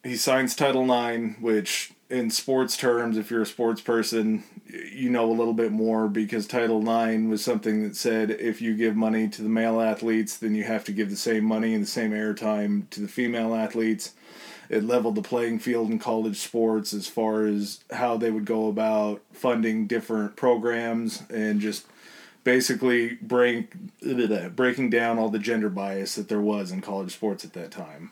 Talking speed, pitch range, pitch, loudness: 190 wpm, 110-120 Hz, 110 Hz, -25 LUFS